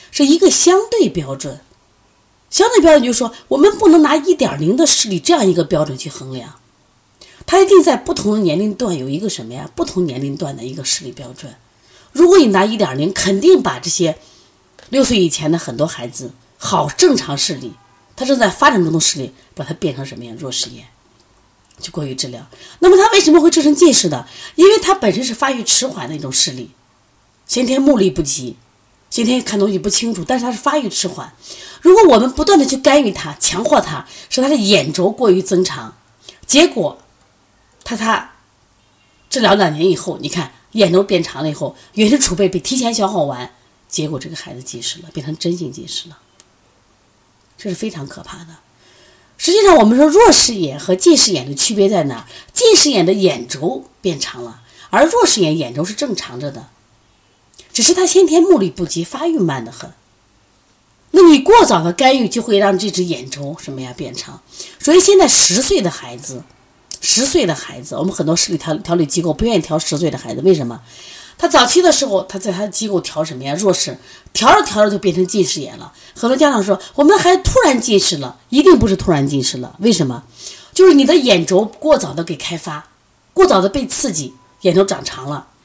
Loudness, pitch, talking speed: -12 LUFS, 185 Hz, 295 characters per minute